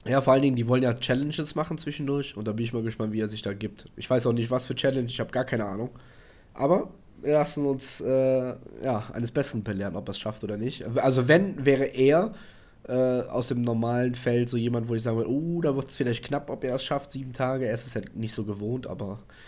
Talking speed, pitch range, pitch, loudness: 255 wpm, 115-135 Hz, 125 Hz, -27 LUFS